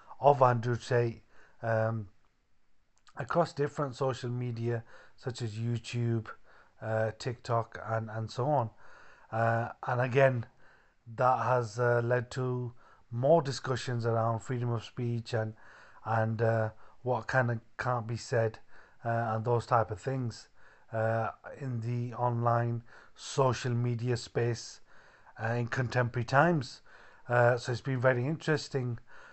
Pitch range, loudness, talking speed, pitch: 115-125 Hz, -31 LUFS, 130 wpm, 120 Hz